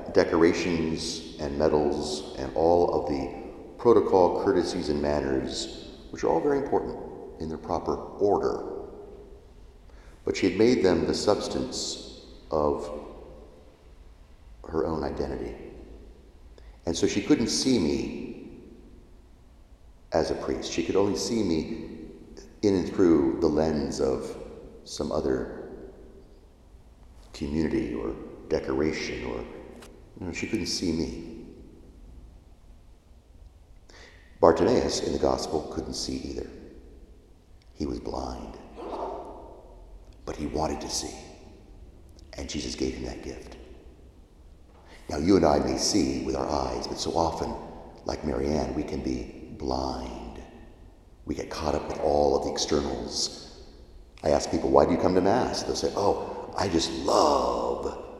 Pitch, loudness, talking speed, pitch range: 80 Hz, -27 LUFS, 130 wpm, 75-85 Hz